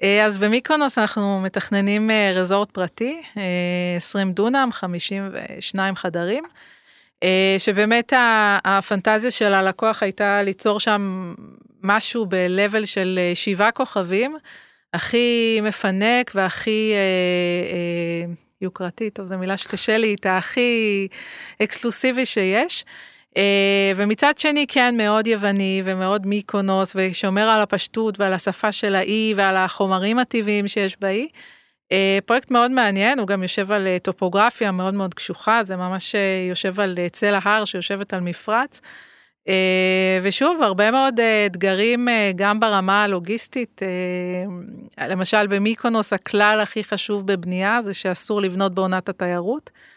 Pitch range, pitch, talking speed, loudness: 190-220 Hz, 200 Hz, 120 wpm, -20 LUFS